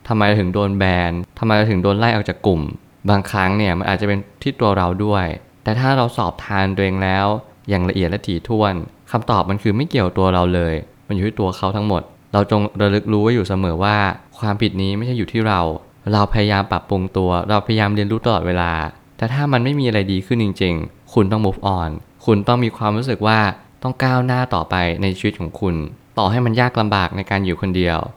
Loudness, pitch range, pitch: -18 LUFS, 95-110 Hz, 100 Hz